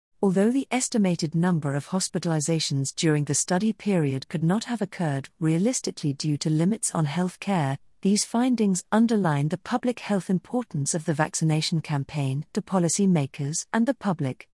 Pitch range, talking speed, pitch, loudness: 155-205 Hz, 155 wpm, 180 Hz, -25 LUFS